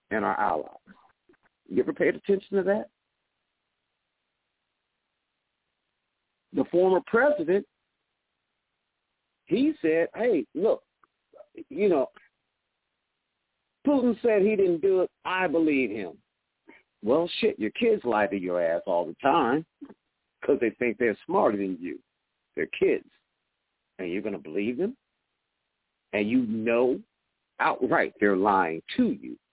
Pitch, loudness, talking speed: 200 Hz, -26 LUFS, 125 wpm